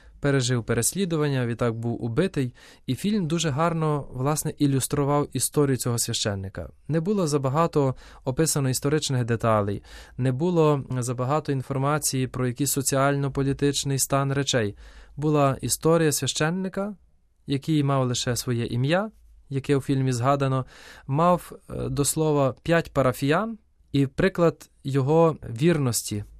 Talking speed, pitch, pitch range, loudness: 115 wpm, 140 Hz, 125-155 Hz, -24 LUFS